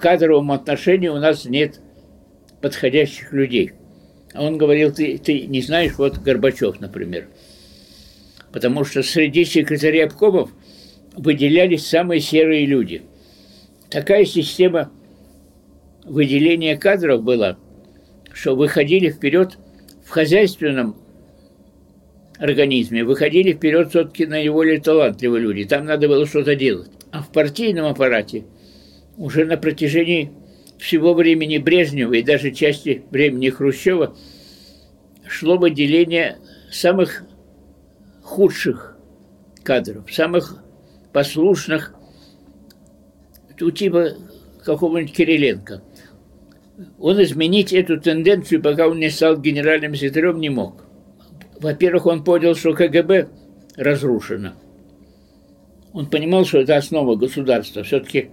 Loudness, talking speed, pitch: -17 LUFS, 100 wpm, 145 Hz